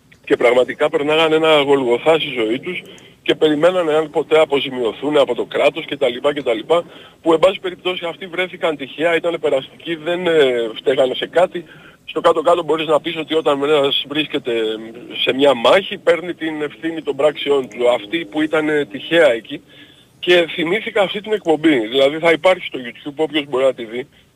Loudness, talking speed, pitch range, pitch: -17 LUFS, 170 wpm, 145-170 Hz, 155 Hz